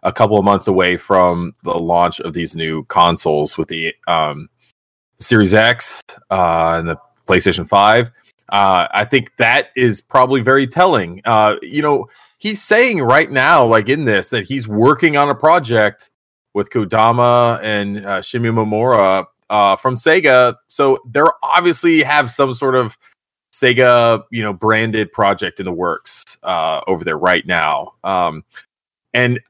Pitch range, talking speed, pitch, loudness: 95-135 Hz, 155 wpm, 115 Hz, -14 LUFS